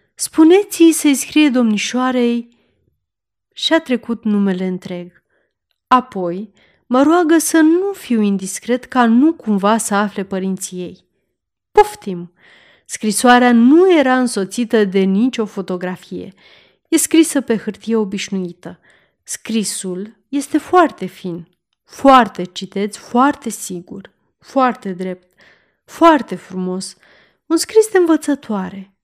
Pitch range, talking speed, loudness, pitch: 190-285 Hz, 105 wpm, -15 LUFS, 225 Hz